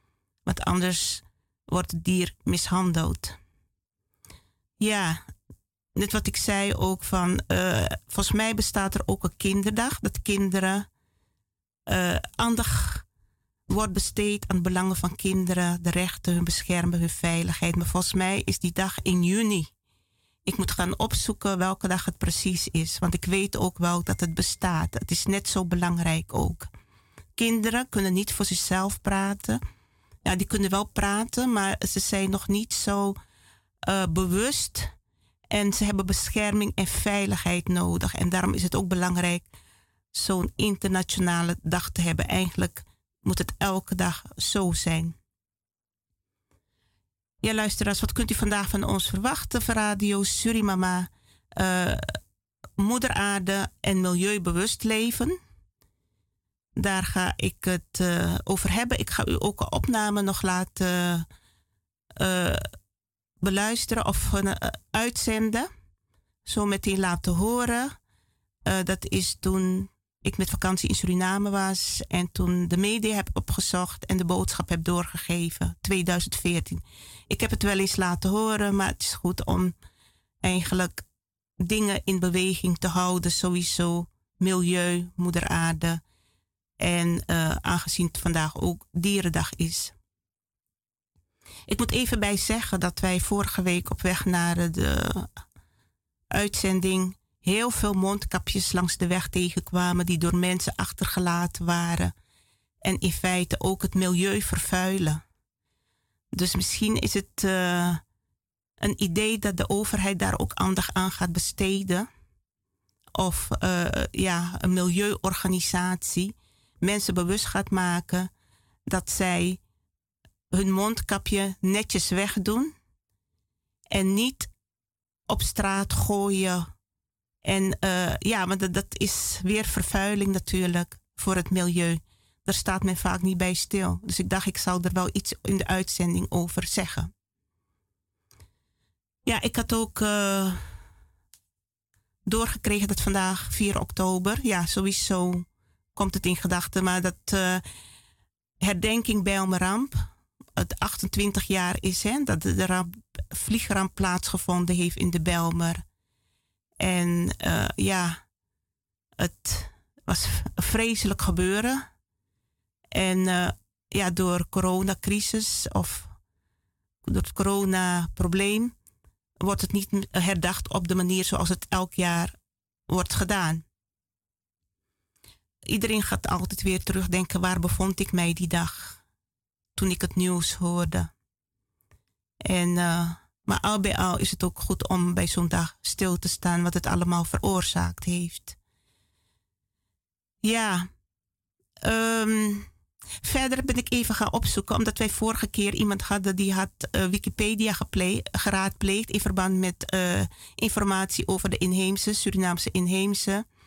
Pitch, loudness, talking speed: 180 Hz, -26 LUFS, 130 wpm